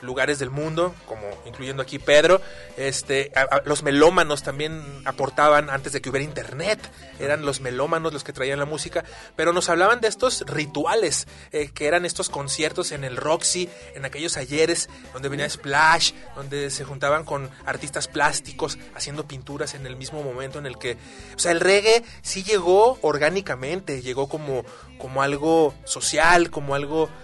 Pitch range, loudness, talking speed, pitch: 135-165 Hz, -22 LUFS, 165 wpm, 145 Hz